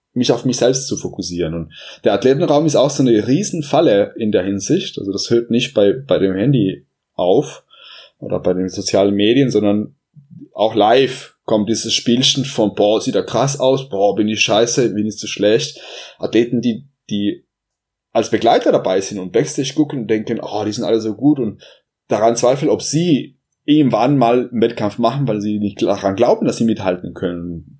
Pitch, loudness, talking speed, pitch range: 115 Hz, -16 LUFS, 190 wpm, 105-135 Hz